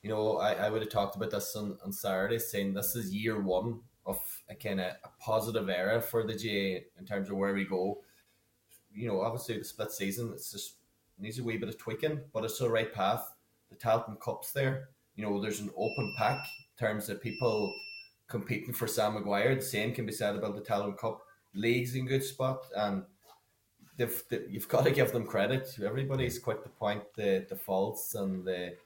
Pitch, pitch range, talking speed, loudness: 110 Hz, 100-120 Hz, 210 wpm, -34 LUFS